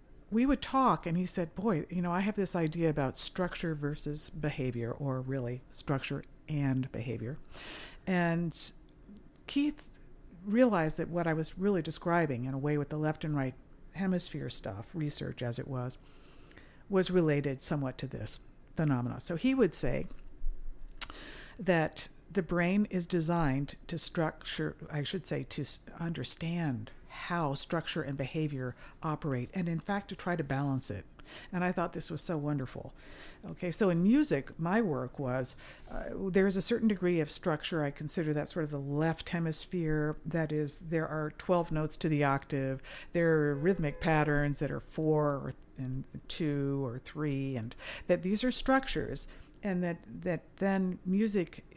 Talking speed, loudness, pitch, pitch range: 165 wpm, -33 LUFS, 155 Hz, 140-180 Hz